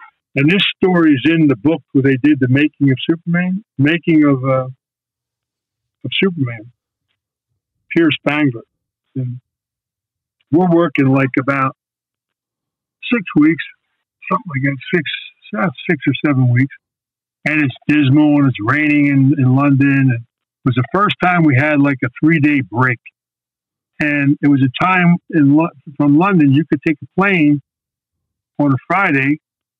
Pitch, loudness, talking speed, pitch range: 140 Hz, -14 LUFS, 150 wpm, 130-155 Hz